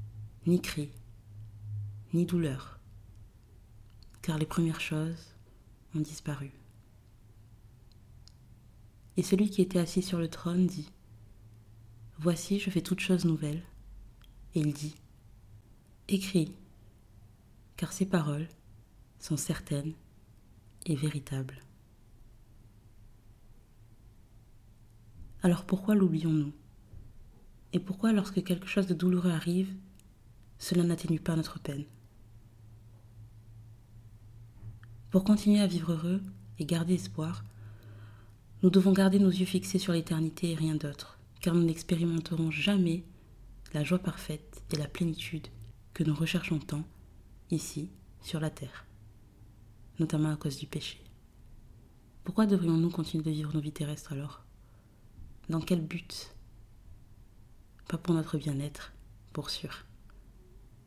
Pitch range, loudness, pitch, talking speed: 110-165 Hz, -32 LUFS, 125 Hz, 110 wpm